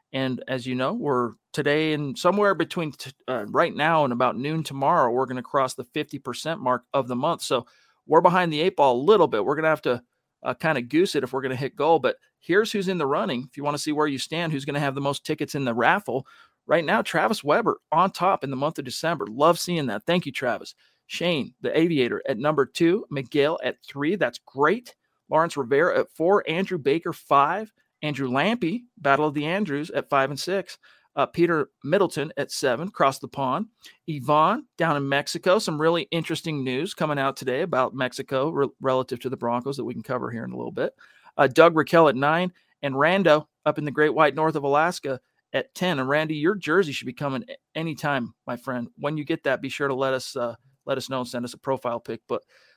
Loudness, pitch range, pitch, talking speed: -24 LUFS, 135-165 Hz, 145 Hz, 230 wpm